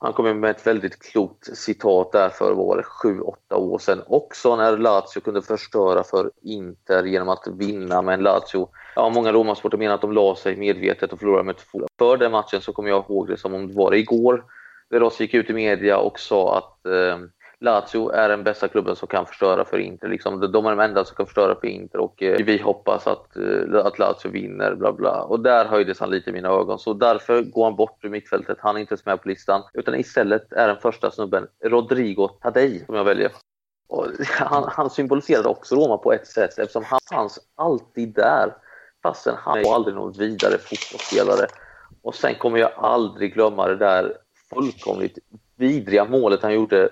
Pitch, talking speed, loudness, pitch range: 110 Hz, 200 wpm, -21 LUFS, 100-130 Hz